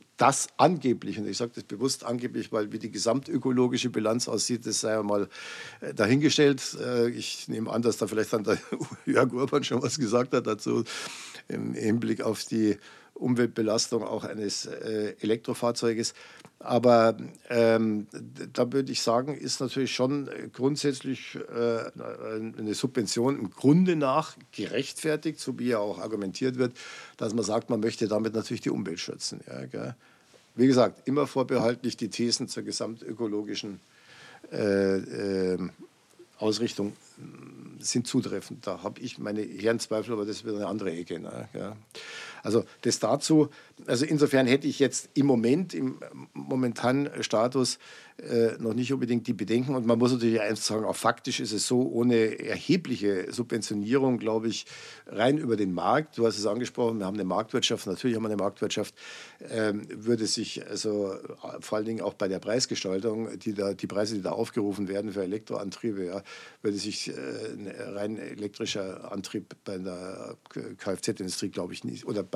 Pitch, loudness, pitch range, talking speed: 115 Hz, -28 LUFS, 105-125 Hz, 160 wpm